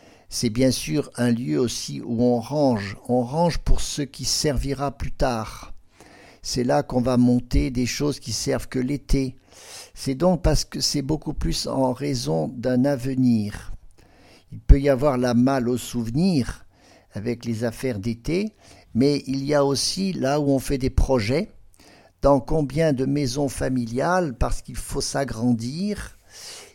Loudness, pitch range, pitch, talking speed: -23 LUFS, 120-145 Hz, 130 Hz, 160 wpm